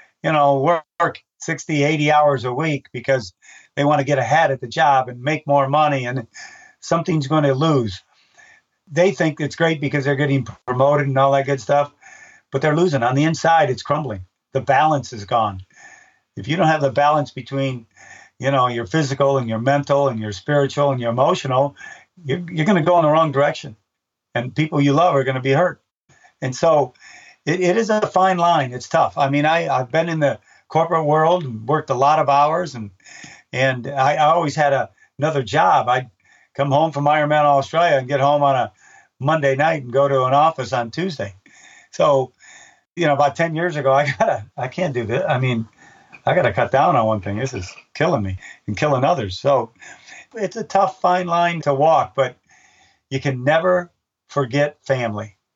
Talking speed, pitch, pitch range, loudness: 200 wpm, 145 Hz, 130-160 Hz, -19 LUFS